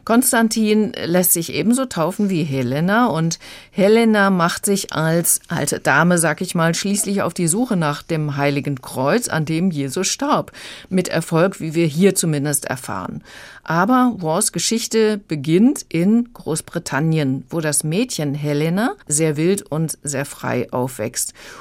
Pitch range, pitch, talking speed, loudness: 150-200 Hz, 170 Hz, 145 wpm, -18 LUFS